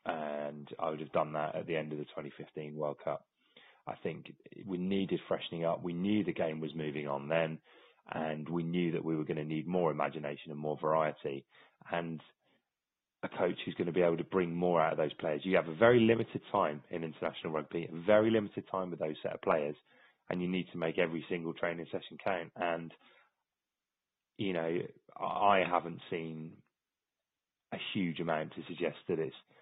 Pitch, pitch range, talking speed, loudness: 80 Hz, 75-90 Hz, 195 wpm, -35 LUFS